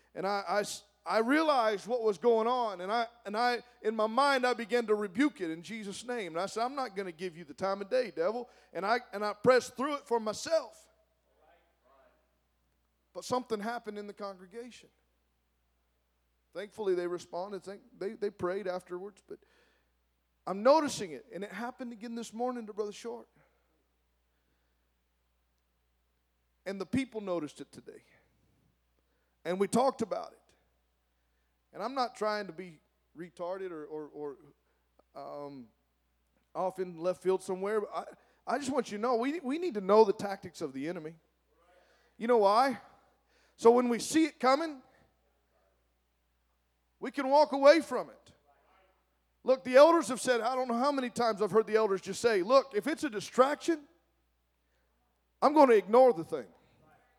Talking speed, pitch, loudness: 170 wpm, 205 Hz, -30 LUFS